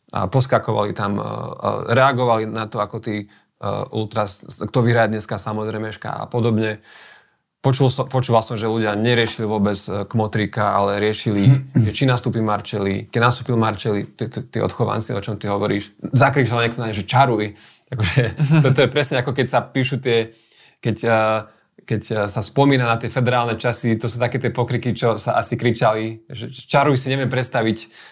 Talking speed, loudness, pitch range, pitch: 160 wpm, -20 LUFS, 110-125 Hz, 115 Hz